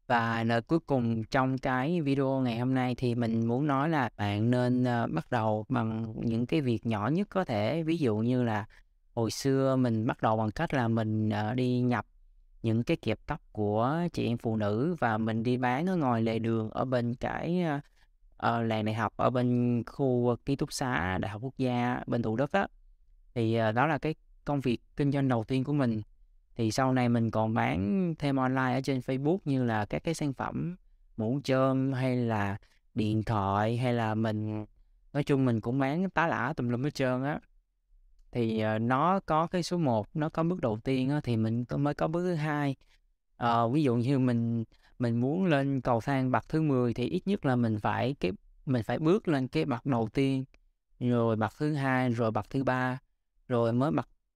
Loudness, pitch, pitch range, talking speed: -30 LUFS, 125 Hz, 115-140 Hz, 210 wpm